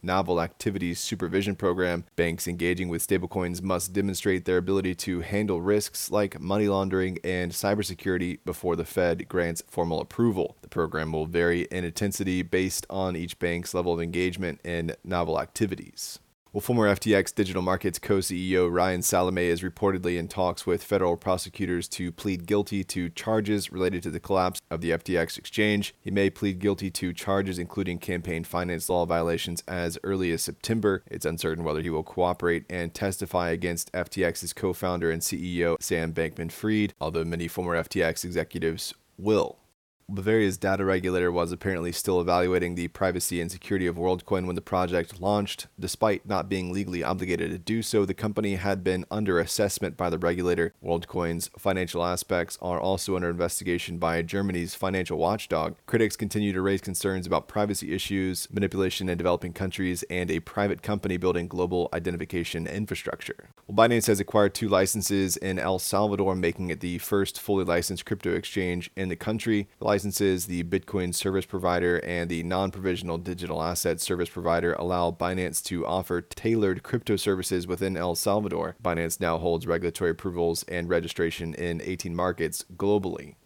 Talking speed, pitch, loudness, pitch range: 165 wpm, 90 Hz, -27 LUFS, 85-95 Hz